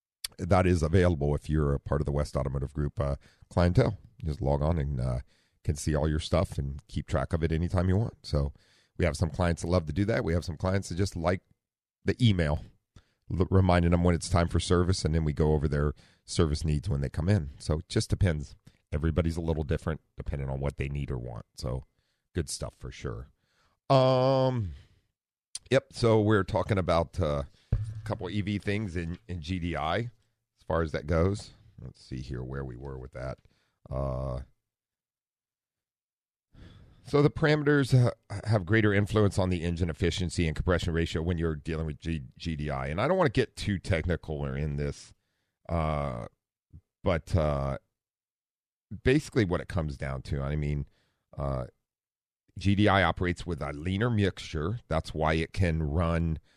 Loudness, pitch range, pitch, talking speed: -29 LUFS, 75-100 Hz, 85 Hz, 185 wpm